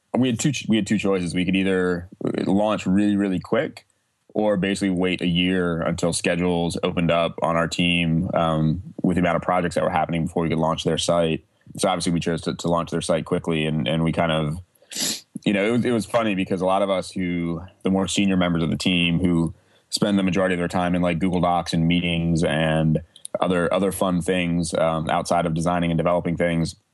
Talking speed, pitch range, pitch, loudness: 225 wpm, 85-95 Hz, 90 Hz, -22 LUFS